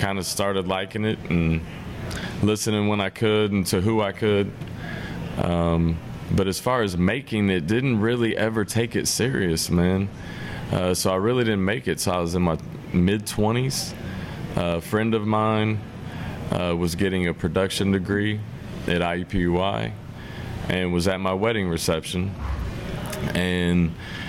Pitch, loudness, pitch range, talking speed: 95 Hz, -24 LUFS, 90-110 Hz, 155 wpm